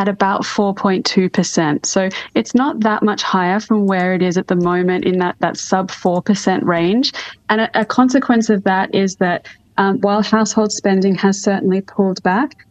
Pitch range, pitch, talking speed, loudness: 185-215 Hz, 195 Hz, 180 wpm, -16 LUFS